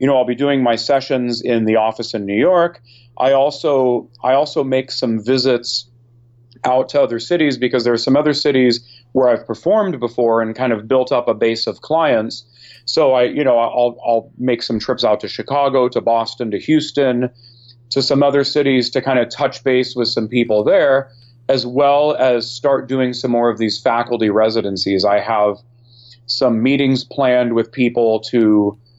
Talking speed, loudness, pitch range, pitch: 190 wpm, -16 LUFS, 115-130 Hz, 120 Hz